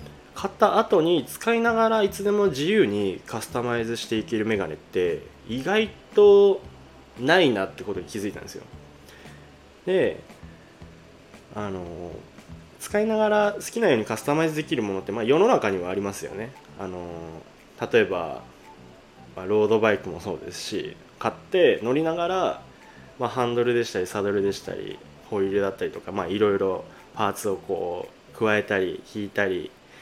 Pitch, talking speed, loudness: 105 Hz, 330 characters per minute, -24 LUFS